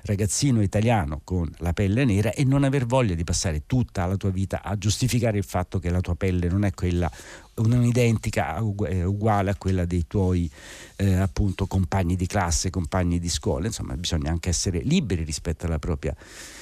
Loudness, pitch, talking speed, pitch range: -24 LUFS, 95 Hz, 180 wpm, 85-105 Hz